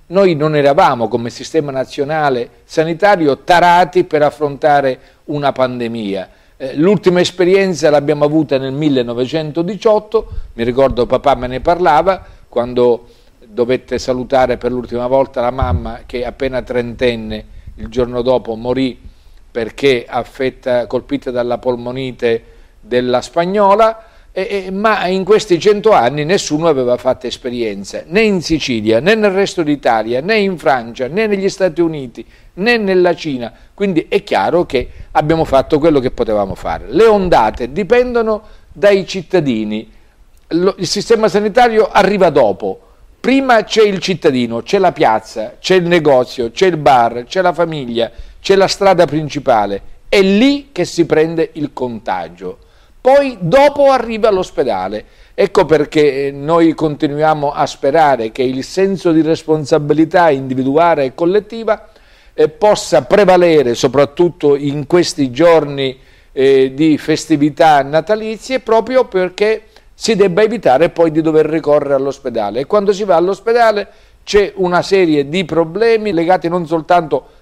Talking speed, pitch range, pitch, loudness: 135 wpm, 125-190 Hz, 155 Hz, -13 LUFS